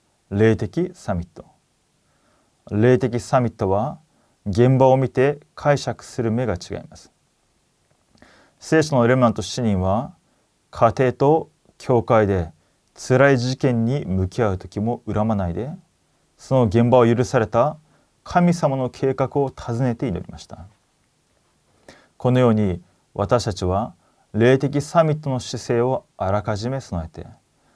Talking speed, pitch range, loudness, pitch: 240 characters per minute, 105-135 Hz, -20 LUFS, 120 Hz